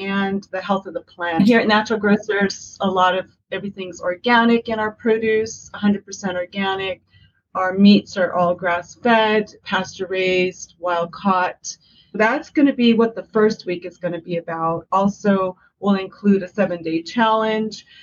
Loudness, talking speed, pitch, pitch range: -19 LUFS, 155 wpm, 195 Hz, 180-215 Hz